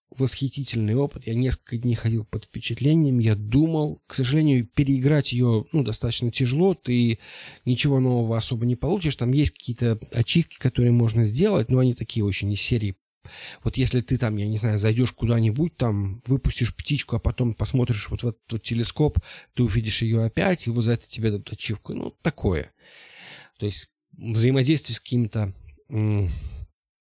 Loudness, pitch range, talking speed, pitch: -24 LUFS, 110-130 Hz, 165 wpm, 120 Hz